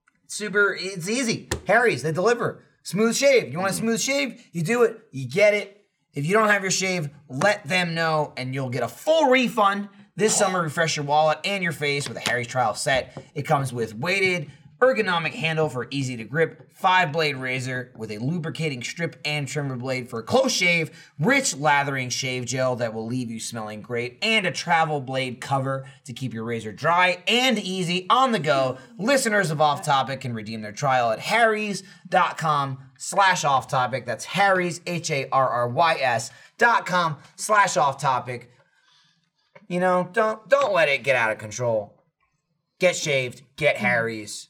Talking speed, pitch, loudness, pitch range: 175 wpm, 155 Hz, -23 LUFS, 130-195 Hz